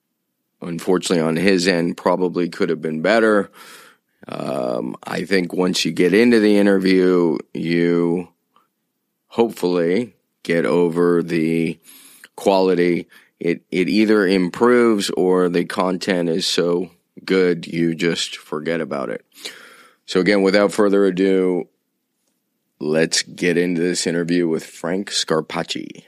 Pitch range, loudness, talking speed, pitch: 85-95 Hz, -18 LUFS, 120 wpm, 90 Hz